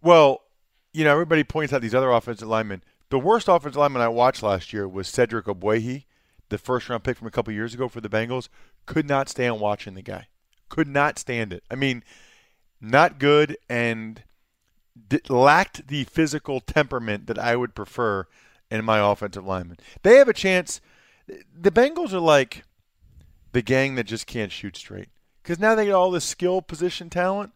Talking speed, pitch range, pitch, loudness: 185 wpm, 105-155 Hz, 125 Hz, -22 LUFS